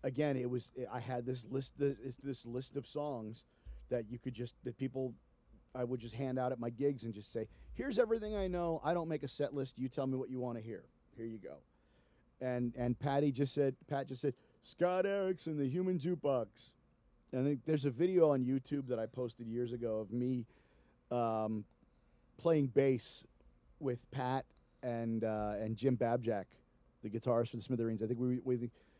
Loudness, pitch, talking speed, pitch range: -38 LUFS, 130 Hz, 205 wpm, 120-140 Hz